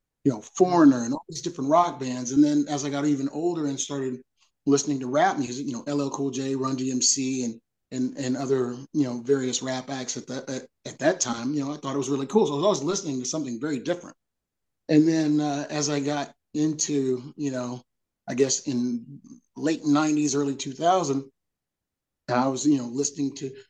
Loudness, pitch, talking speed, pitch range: -25 LUFS, 140 Hz, 210 wpm, 130-150 Hz